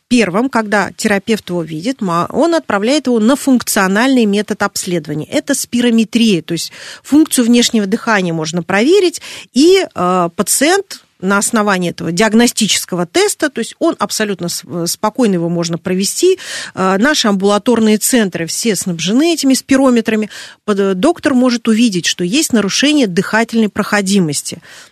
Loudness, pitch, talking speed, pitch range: -13 LUFS, 220 Hz, 125 wpm, 190-250 Hz